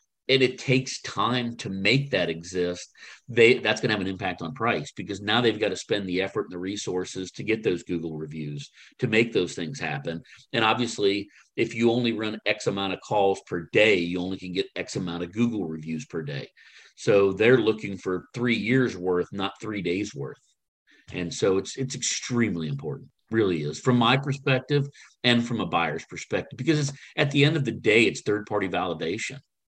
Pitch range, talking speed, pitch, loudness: 90-125 Hz, 200 wpm, 105 Hz, -25 LUFS